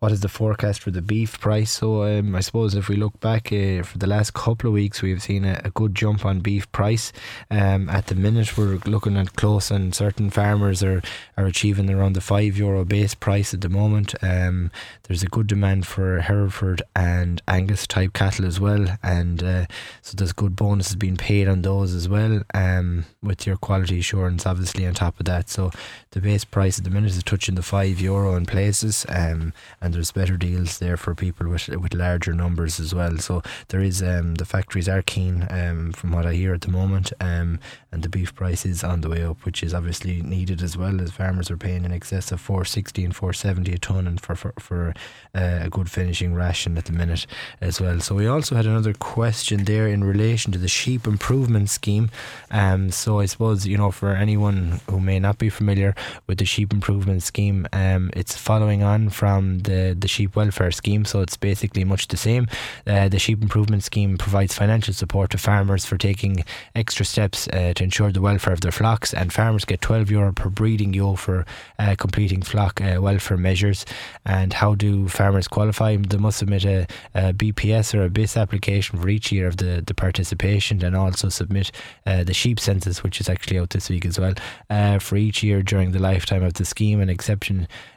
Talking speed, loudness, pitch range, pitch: 210 wpm, -22 LUFS, 90-105 Hz, 100 Hz